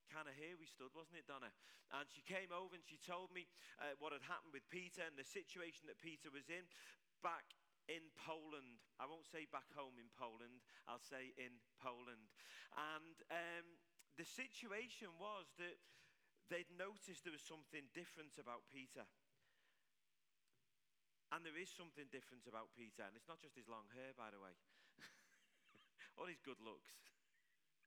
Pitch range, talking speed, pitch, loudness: 130-175 Hz, 170 wpm, 155 Hz, -55 LUFS